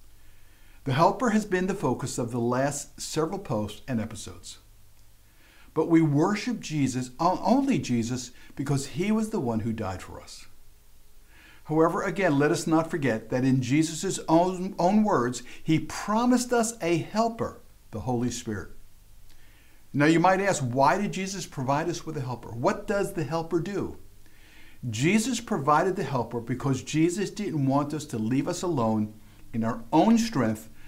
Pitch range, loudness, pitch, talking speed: 110-180 Hz, -26 LUFS, 140 Hz, 160 wpm